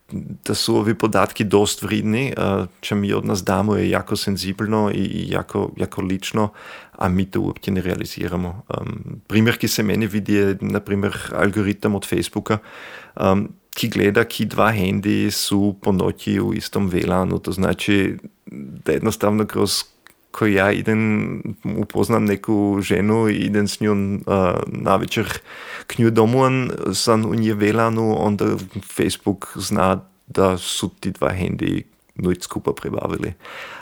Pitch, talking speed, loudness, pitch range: 105 Hz, 140 wpm, -20 LUFS, 100-110 Hz